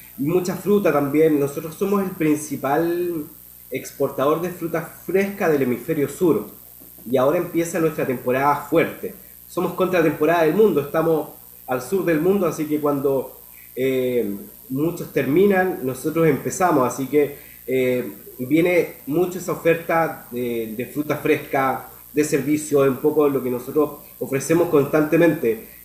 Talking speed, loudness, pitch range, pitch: 135 wpm, -21 LUFS, 135-165 Hz, 150 Hz